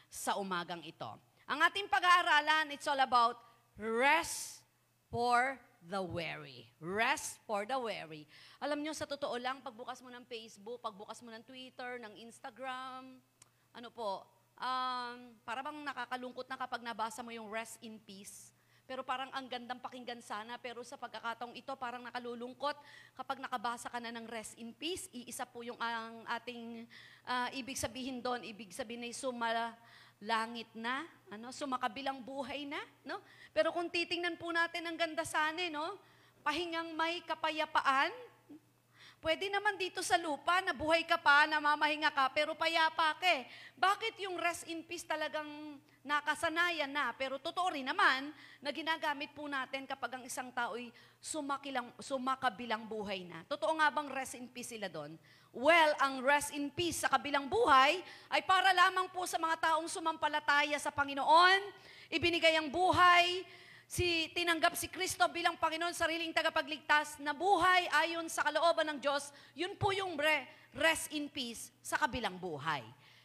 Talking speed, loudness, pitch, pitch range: 160 wpm, -34 LUFS, 280 Hz, 240-325 Hz